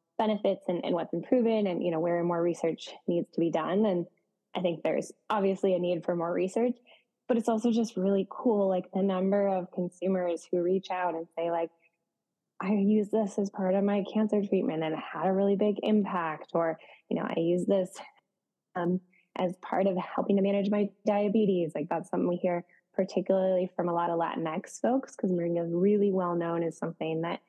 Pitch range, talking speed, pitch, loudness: 170-205 Hz, 205 wpm, 185 Hz, -29 LUFS